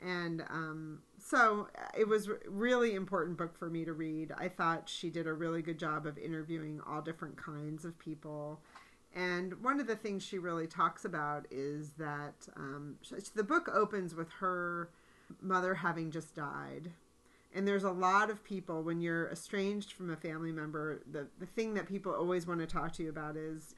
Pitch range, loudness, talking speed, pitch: 155-190 Hz, -37 LUFS, 190 wpm, 170 Hz